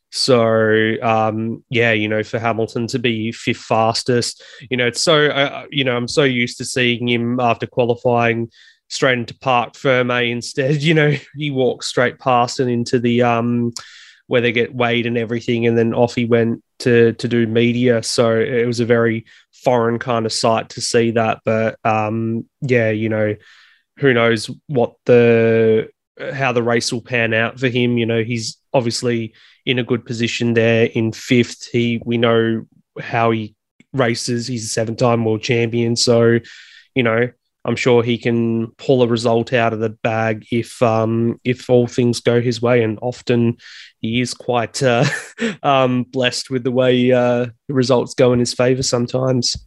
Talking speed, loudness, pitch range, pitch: 180 wpm, -17 LUFS, 115-125 Hz, 120 Hz